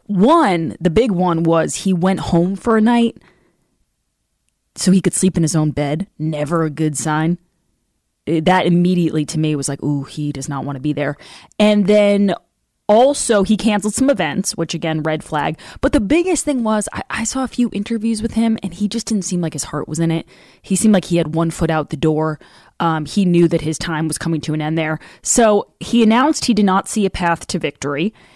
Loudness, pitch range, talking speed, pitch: -17 LUFS, 155-210 Hz, 220 wpm, 175 Hz